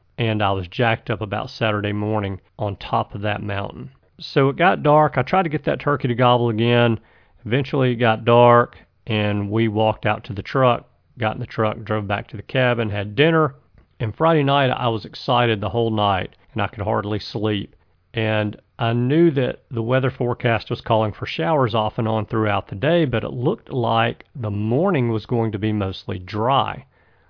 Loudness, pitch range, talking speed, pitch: -20 LUFS, 105-125 Hz, 200 wpm, 115 Hz